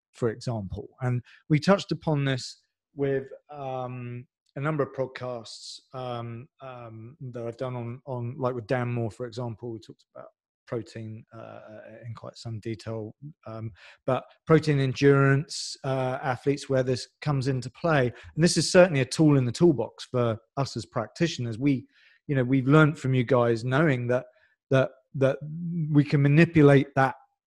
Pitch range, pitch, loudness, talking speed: 120-145 Hz, 130 Hz, -26 LUFS, 165 wpm